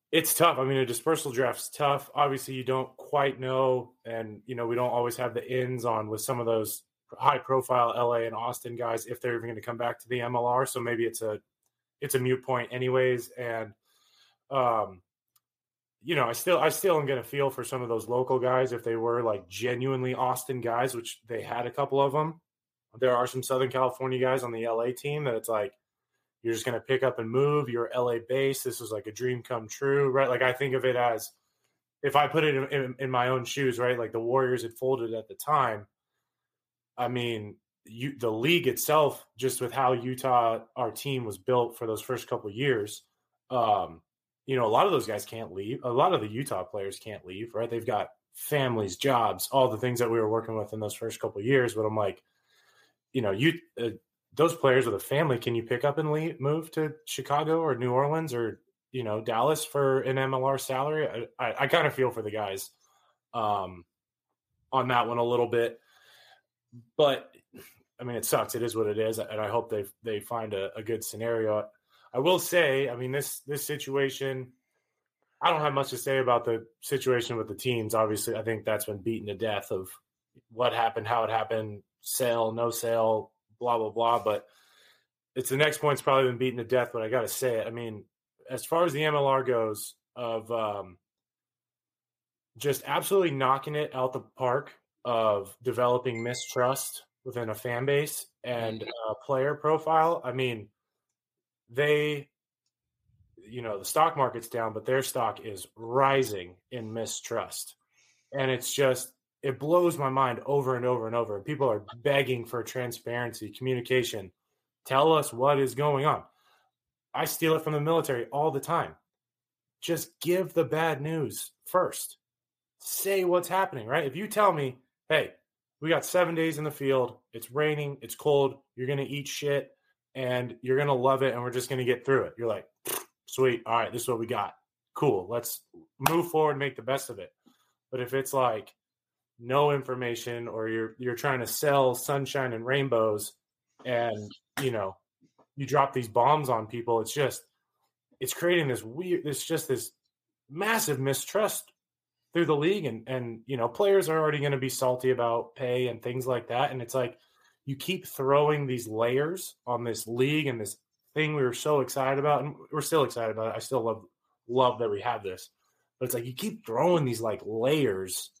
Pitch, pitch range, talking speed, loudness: 125 Hz, 115-140 Hz, 200 wpm, -29 LUFS